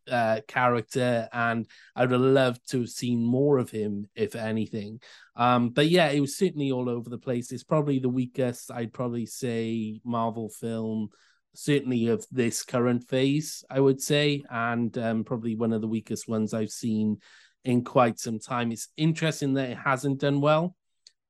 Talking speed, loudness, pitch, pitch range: 175 wpm, -27 LUFS, 120 Hz, 115-135 Hz